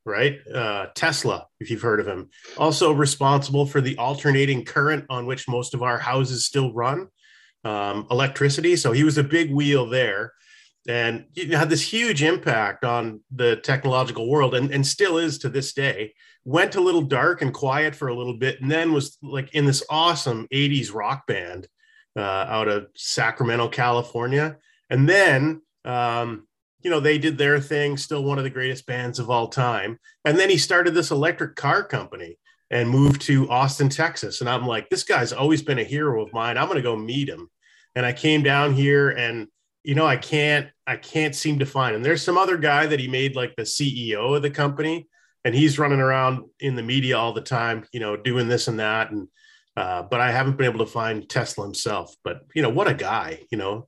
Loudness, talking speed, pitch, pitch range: -22 LUFS, 205 wpm, 135 Hz, 120-150 Hz